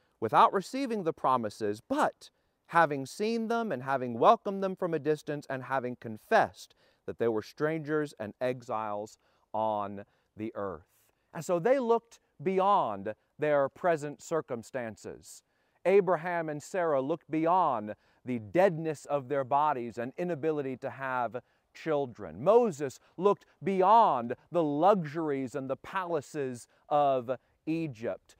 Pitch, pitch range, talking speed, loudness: 145 Hz, 125-175 Hz, 125 wpm, -30 LUFS